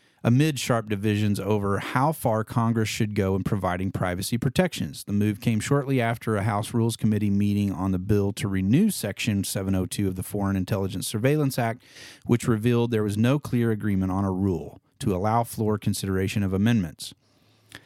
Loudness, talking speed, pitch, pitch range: -25 LUFS, 175 wpm, 105 Hz, 100-120 Hz